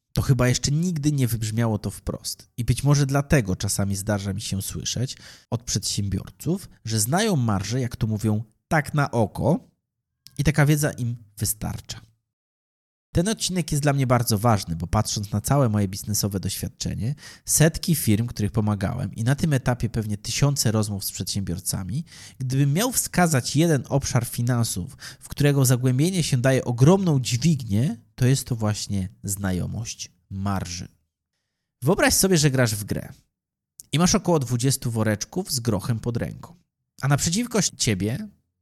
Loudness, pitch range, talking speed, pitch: -23 LUFS, 105-140 Hz, 150 wpm, 120 Hz